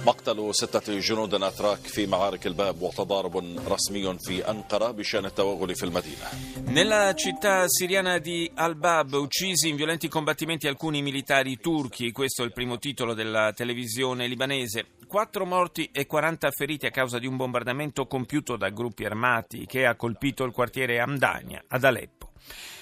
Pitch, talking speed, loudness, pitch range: 130 Hz, 120 wpm, -26 LUFS, 115-155 Hz